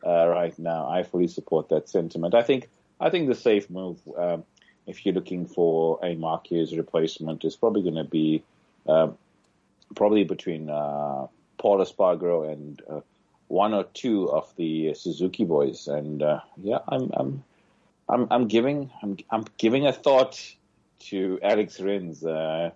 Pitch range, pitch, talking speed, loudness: 80-100 Hz, 85 Hz, 160 wpm, -25 LUFS